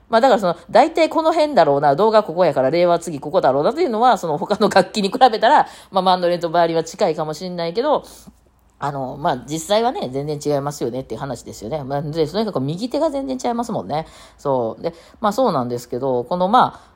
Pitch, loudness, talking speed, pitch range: 175 Hz, -18 LUFS, 460 characters per minute, 150-225 Hz